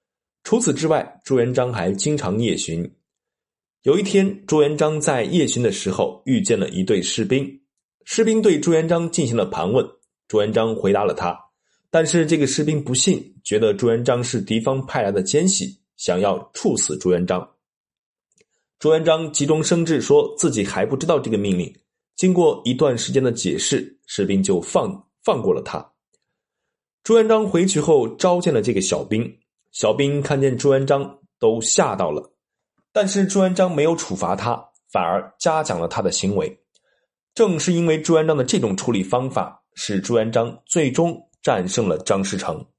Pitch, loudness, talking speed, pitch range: 155 Hz, -20 LUFS, 255 characters per minute, 125-180 Hz